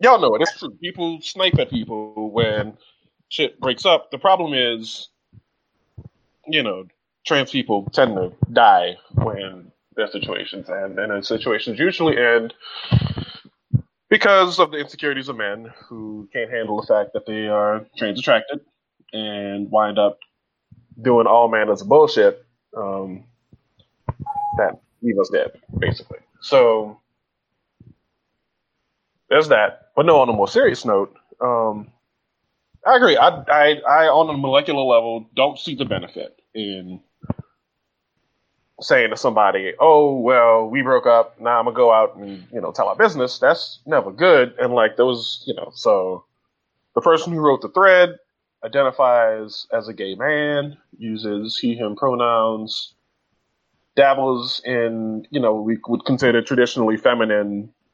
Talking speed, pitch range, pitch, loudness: 145 wpm, 110-150 Hz, 120 Hz, -18 LUFS